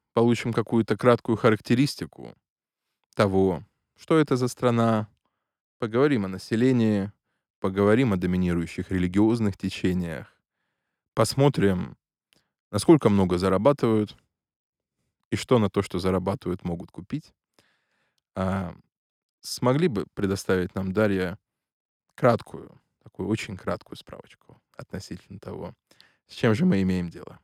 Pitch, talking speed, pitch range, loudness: 100 Hz, 105 wpm, 95-115 Hz, -24 LUFS